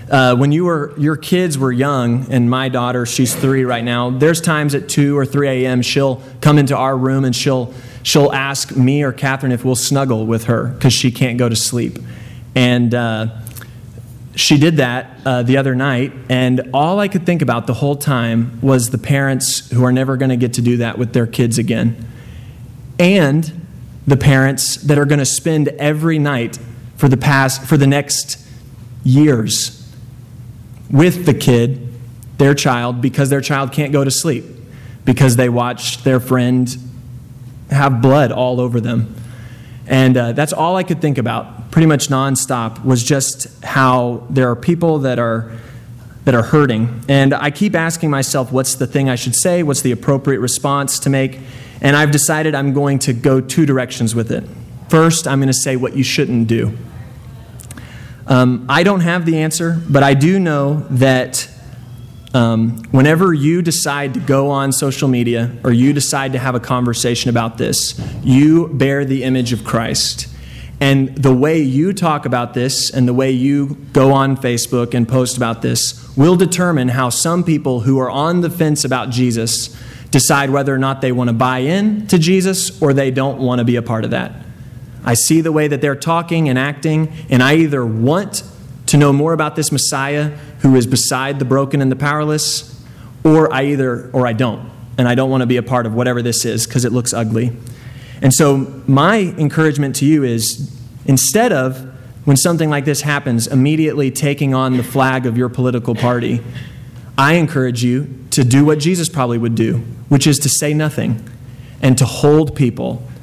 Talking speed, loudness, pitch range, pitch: 190 wpm, -14 LUFS, 125-145 Hz, 130 Hz